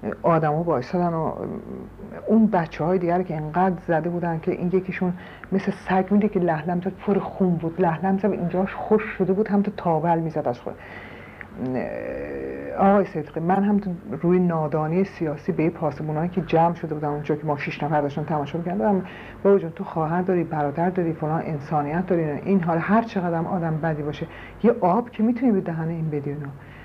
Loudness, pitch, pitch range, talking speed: -23 LUFS, 175 Hz, 155-190 Hz, 185 wpm